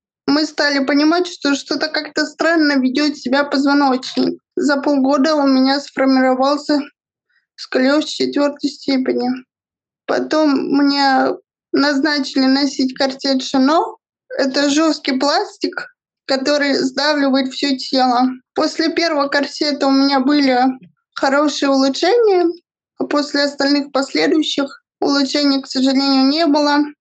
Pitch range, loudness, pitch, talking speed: 270-305 Hz, -16 LUFS, 285 Hz, 105 wpm